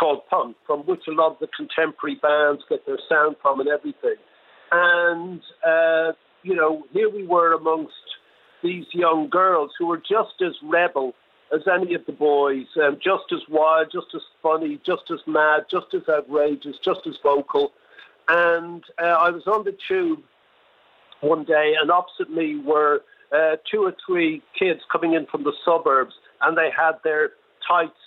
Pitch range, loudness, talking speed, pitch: 155-215 Hz, -21 LUFS, 175 wpm, 170 Hz